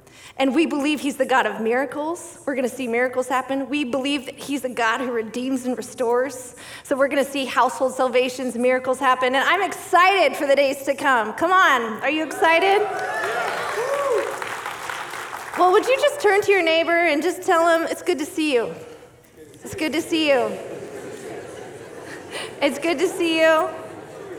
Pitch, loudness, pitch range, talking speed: 290 Hz, -21 LUFS, 260-360 Hz, 180 wpm